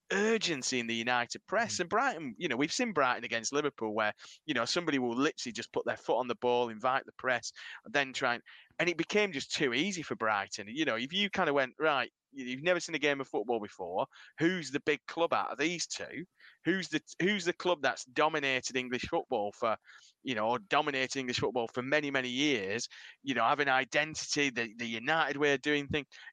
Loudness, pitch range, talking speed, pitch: -32 LUFS, 125-160 Hz, 225 wpm, 145 Hz